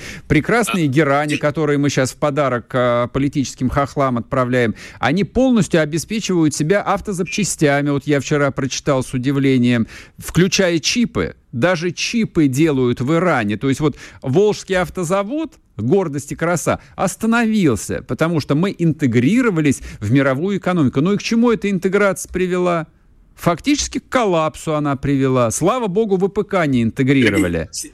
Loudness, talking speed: -17 LUFS, 130 wpm